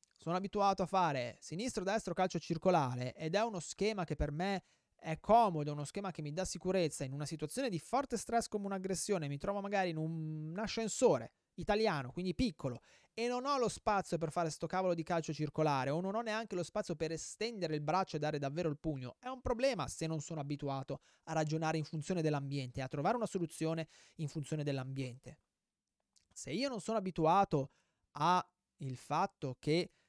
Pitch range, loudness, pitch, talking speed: 150-200 Hz, -37 LUFS, 170 Hz, 185 wpm